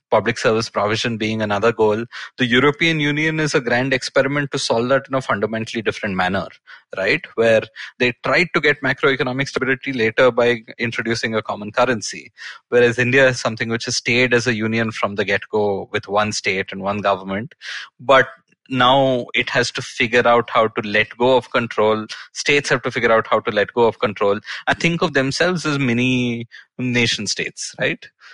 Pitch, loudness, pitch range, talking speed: 120 Hz, -18 LUFS, 110-135 Hz, 185 wpm